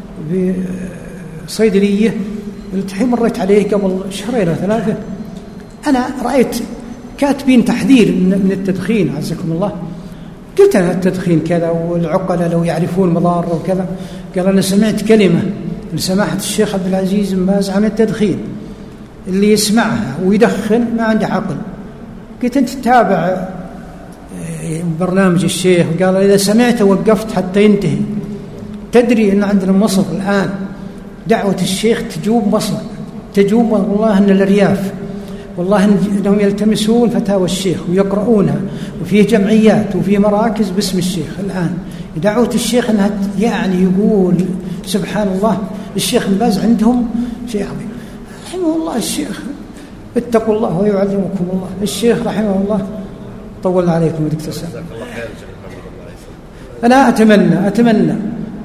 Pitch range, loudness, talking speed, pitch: 185-215 Hz, -14 LUFS, 110 wpm, 200 Hz